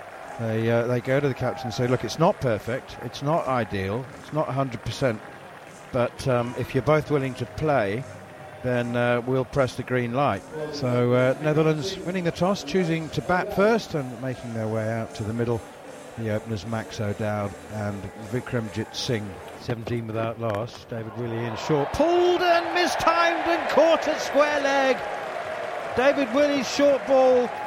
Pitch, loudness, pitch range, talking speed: 130 Hz, -25 LUFS, 115-170 Hz, 165 wpm